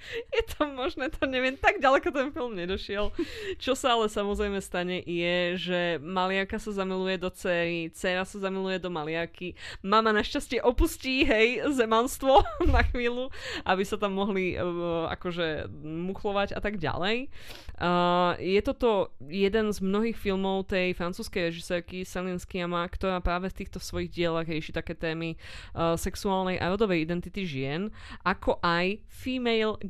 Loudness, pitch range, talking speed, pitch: -28 LUFS, 175-225 Hz, 150 wpm, 190 Hz